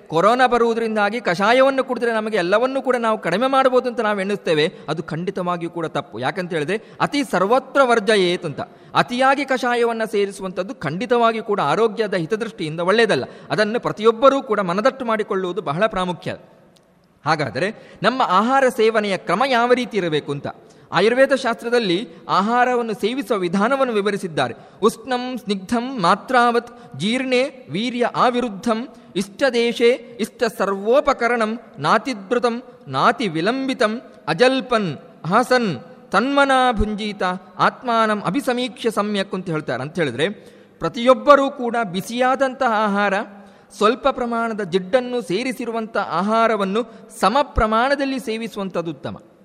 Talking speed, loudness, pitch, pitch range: 105 wpm, -19 LUFS, 225 Hz, 195-245 Hz